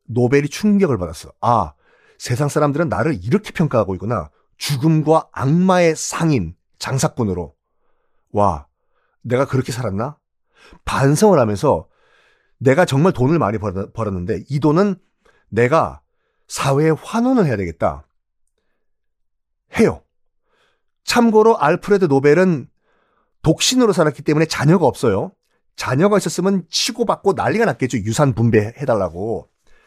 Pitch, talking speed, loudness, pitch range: 145 Hz, 275 characters per minute, -17 LUFS, 110-185 Hz